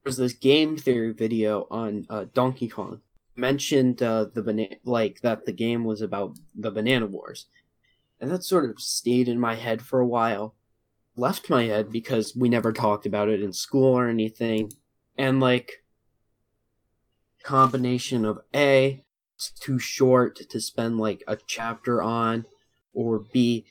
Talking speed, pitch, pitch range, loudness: 155 wpm, 115 Hz, 110-125 Hz, -25 LUFS